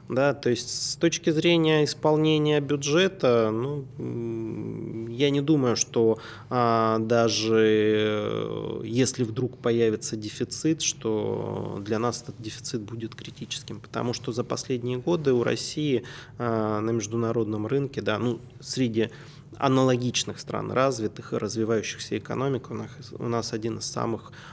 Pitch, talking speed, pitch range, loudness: 120 Hz, 130 wpm, 115-140 Hz, -26 LUFS